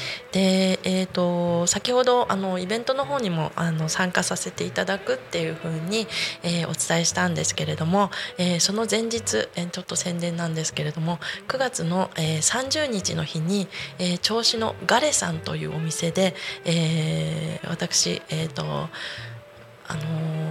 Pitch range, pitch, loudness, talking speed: 160-200 Hz, 175 Hz, -24 LUFS, 295 characters per minute